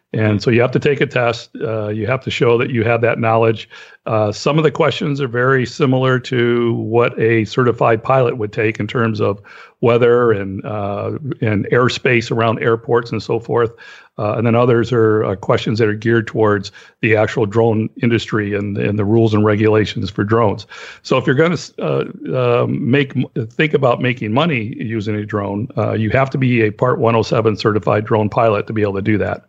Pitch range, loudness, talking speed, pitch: 110-125 Hz, -16 LUFS, 205 wpm, 115 Hz